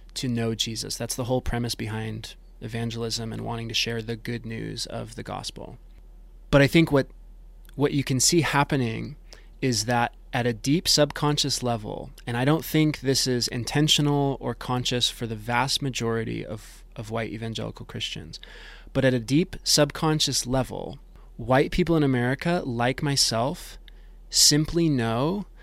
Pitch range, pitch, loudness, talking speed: 115-145 Hz, 125 Hz, -24 LUFS, 155 wpm